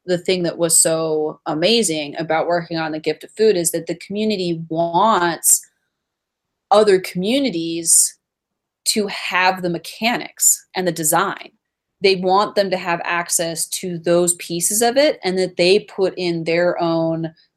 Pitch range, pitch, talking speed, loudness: 165-195 Hz, 175 Hz, 155 wpm, -17 LUFS